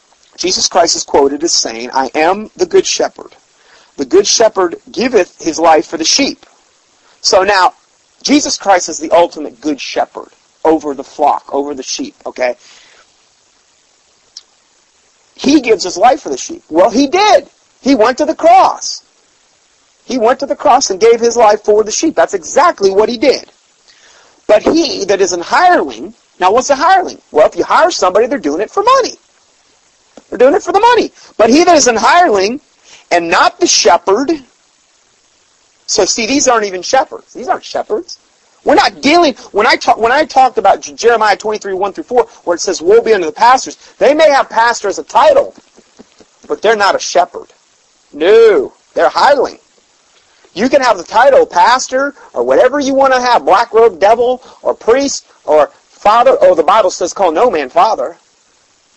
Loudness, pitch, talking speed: -11 LUFS, 265 Hz, 180 wpm